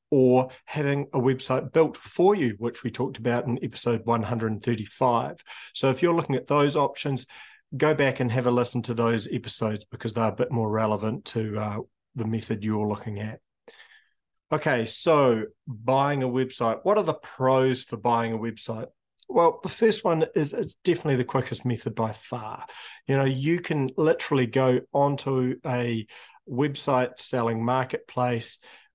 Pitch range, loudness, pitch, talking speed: 115-140 Hz, -25 LUFS, 125 Hz, 165 wpm